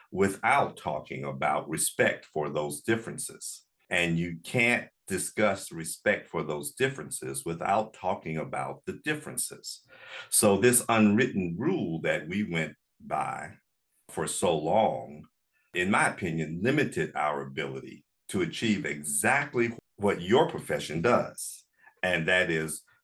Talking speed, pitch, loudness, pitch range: 120 wpm, 85 Hz, -28 LUFS, 75-105 Hz